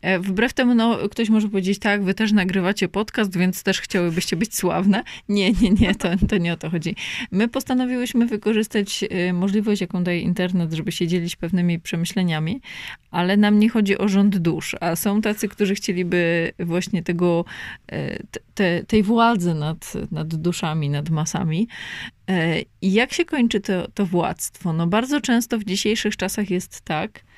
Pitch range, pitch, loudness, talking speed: 175-215 Hz, 195 Hz, -21 LUFS, 160 wpm